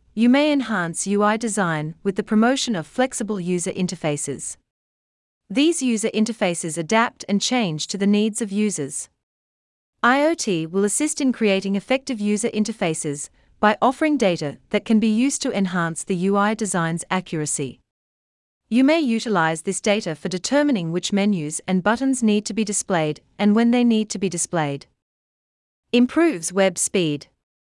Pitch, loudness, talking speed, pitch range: 200 Hz, -21 LUFS, 150 wpm, 165-230 Hz